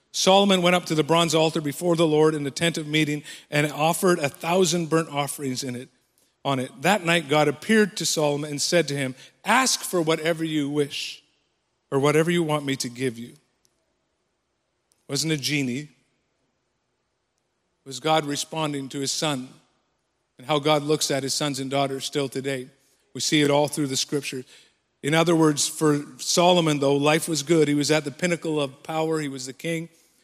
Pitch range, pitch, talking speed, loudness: 140-165 Hz, 150 Hz, 190 wpm, -23 LUFS